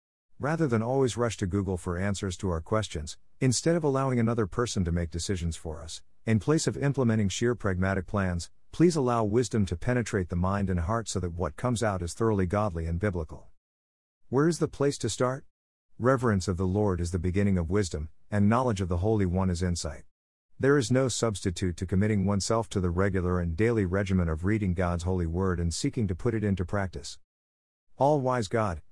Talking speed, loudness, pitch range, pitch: 205 wpm, -28 LUFS, 90-115 Hz, 100 Hz